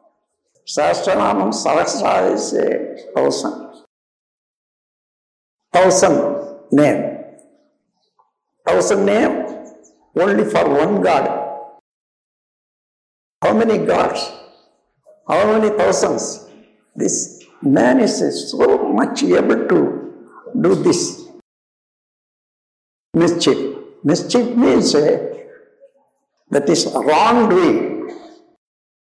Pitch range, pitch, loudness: 295-440 Hz, 340 Hz, -16 LUFS